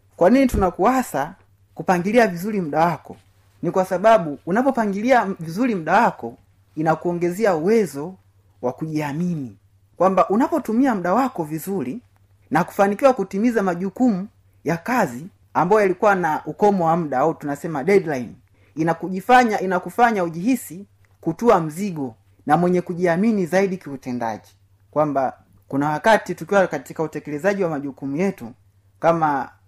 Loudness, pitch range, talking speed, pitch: -20 LUFS, 135-200 Hz, 115 wpm, 170 Hz